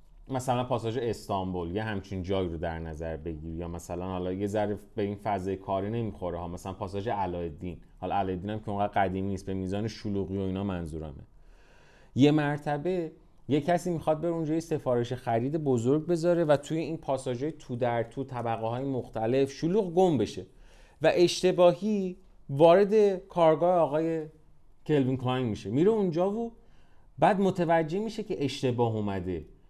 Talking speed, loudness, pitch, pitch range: 160 wpm, -29 LUFS, 125 Hz, 95-160 Hz